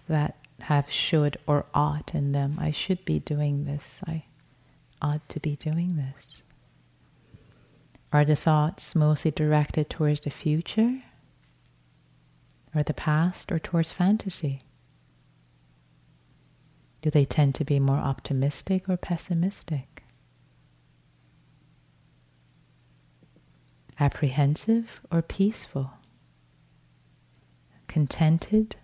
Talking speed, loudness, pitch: 95 wpm, -26 LUFS, 145 Hz